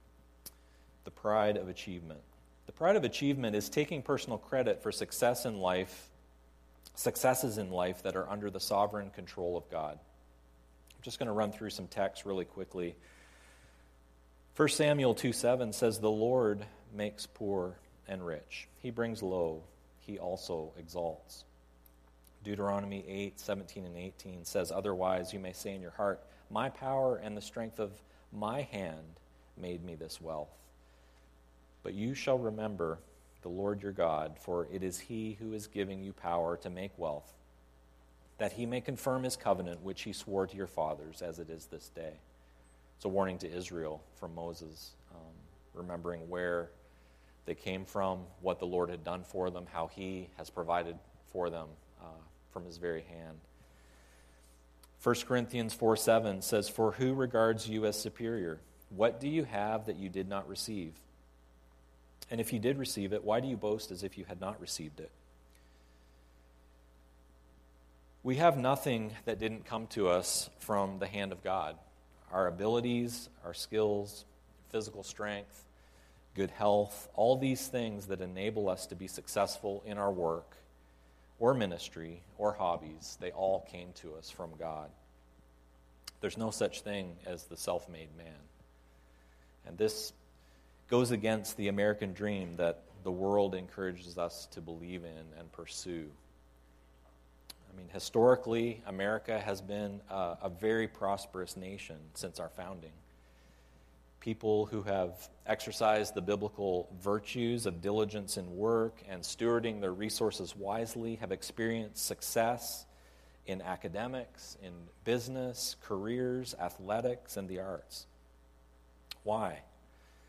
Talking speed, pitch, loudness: 145 wpm, 90 Hz, -36 LUFS